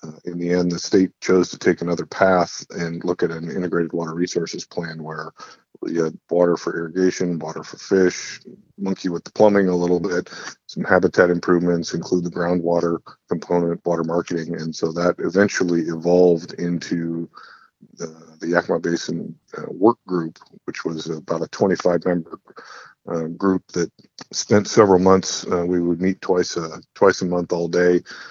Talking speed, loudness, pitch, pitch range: 165 wpm, -21 LUFS, 85 Hz, 85-90 Hz